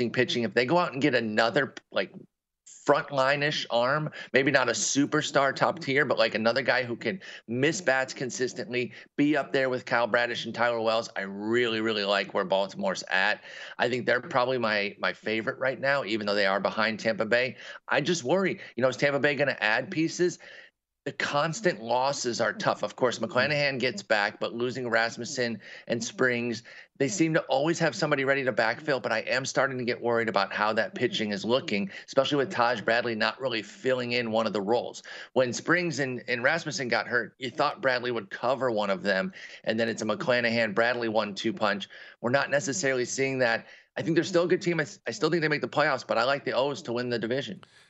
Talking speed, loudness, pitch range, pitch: 215 wpm, -27 LUFS, 115-140 Hz, 125 Hz